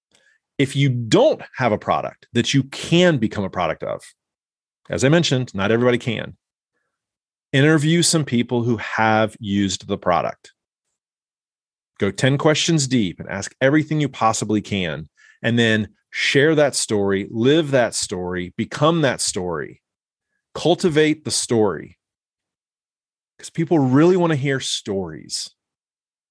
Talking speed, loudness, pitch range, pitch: 130 wpm, -19 LUFS, 110-155 Hz, 130 Hz